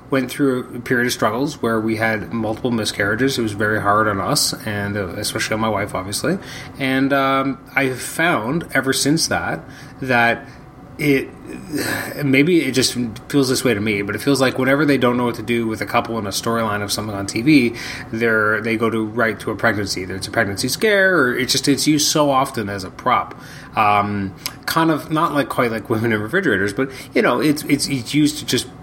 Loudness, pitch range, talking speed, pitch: -18 LUFS, 110-135 Hz, 220 wpm, 120 Hz